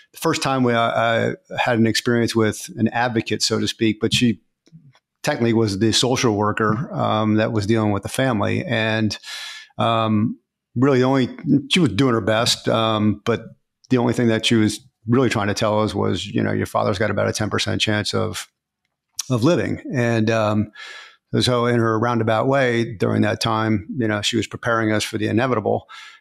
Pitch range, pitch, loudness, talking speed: 110-120 Hz, 115 Hz, -20 LUFS, 190 wpm